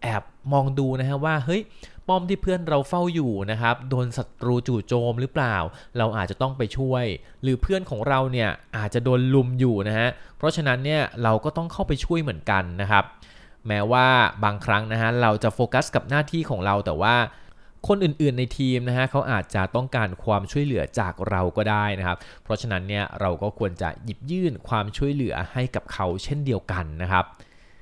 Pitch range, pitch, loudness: 105-135 Hz, 120 Hz, -24 LUFS